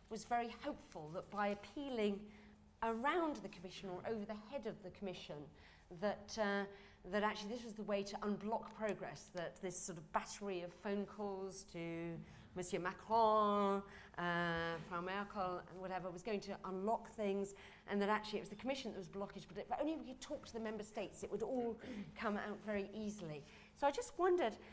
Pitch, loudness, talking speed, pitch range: 205 Hz, -43 LUFS, 190 wpm, 185-220 Hz